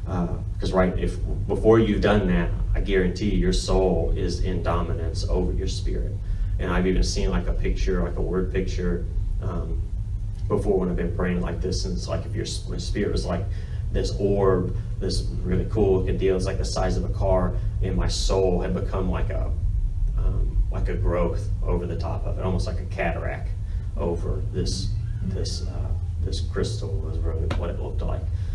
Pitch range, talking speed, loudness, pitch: 90-100 Hz, 195 wpm, -26 LUFS, 95 Hz